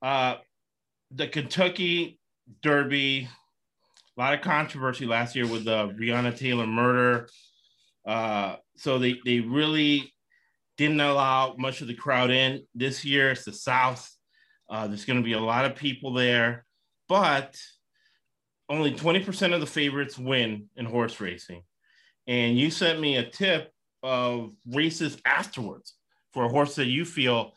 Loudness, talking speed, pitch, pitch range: -26 LUFS, 145 wpm, 130 Hz, 120-145 Hz